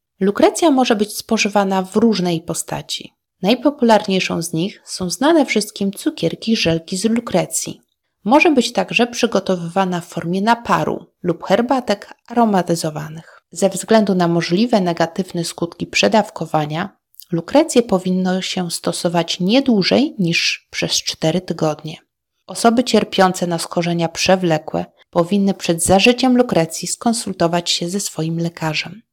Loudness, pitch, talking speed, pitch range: -17 LUFS, 190 Hz, 120 wpm, 170-225 Hz